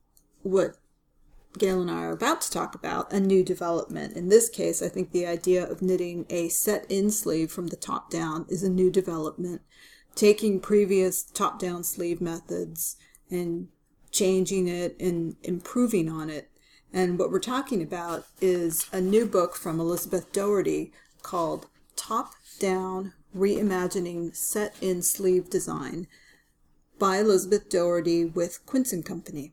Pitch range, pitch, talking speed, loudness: 170-195 Hz, 180 Hz, 140 wpm, -27 LUFS